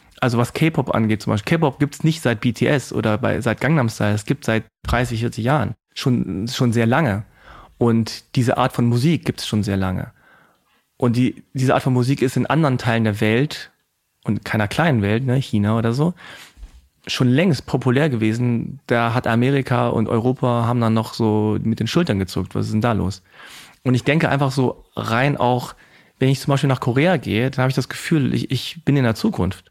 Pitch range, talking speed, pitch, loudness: 110-135 Hz, 210 wpm, 120 Hz, -20 LUFS